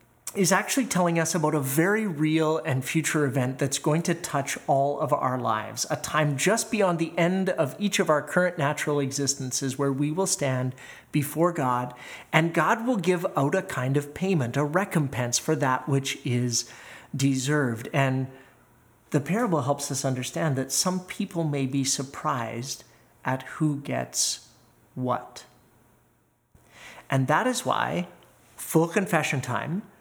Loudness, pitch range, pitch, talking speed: -26 LUFS, 130-170 Hz, 145 Hz, 155 wpm